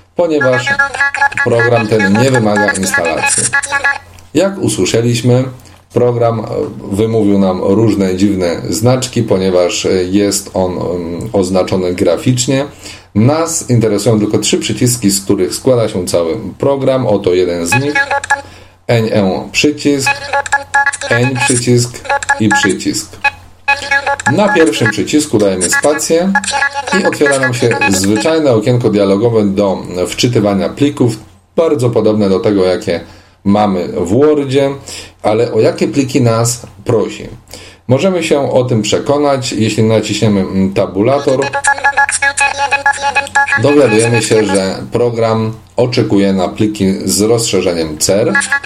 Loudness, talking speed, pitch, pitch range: -12 LUFS, 105 wpm, 120 Hz, 100-150 Hz